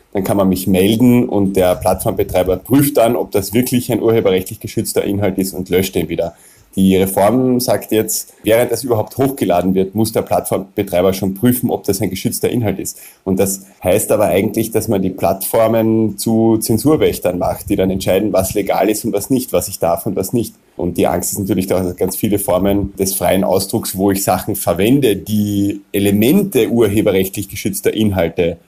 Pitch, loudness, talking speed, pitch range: 100 Hz, -15 LUFS, 190 wpm, 95-115 Hz